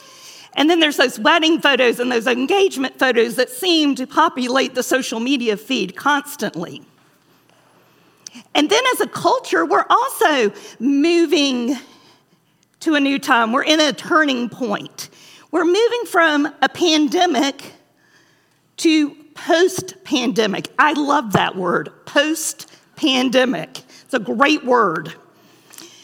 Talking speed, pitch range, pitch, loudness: 125 wpm, 255-330 Hz, 290 Hz, -17 LUFS